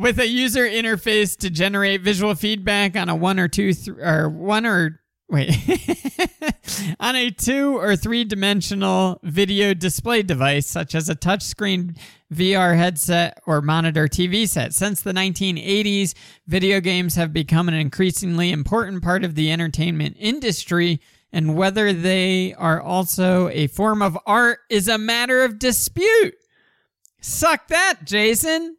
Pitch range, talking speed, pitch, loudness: 170-220 Hz, 145 wpm, 190 Hz, -19 LUFS